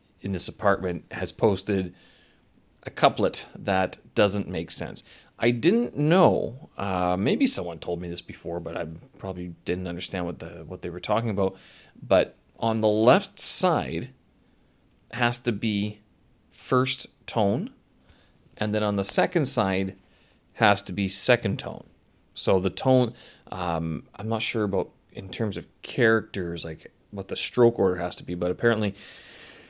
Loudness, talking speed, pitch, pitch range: -25 LUFS, 155 wpm, 100 Hz, 90-115 Hz